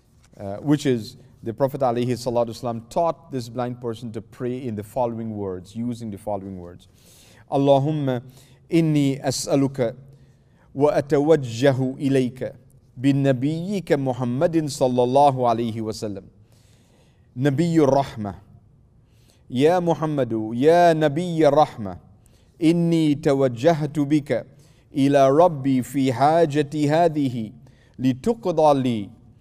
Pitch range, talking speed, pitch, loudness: 115-145 Hz, 95 wpm, 130 Hz, -21 LUFS